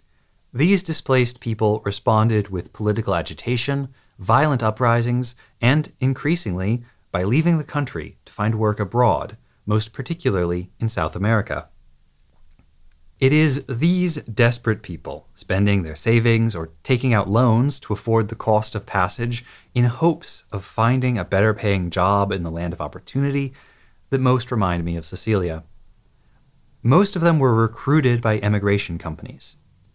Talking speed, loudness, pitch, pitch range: 140 wpm, -21 LUFS, 110 Hz, 95-125 Hz